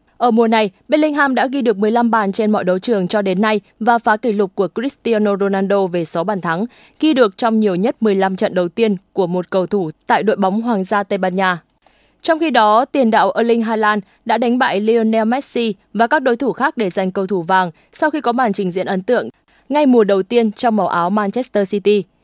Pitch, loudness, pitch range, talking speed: 215 Hz, -16 LUFS, 195-235 Hz, 235 wpm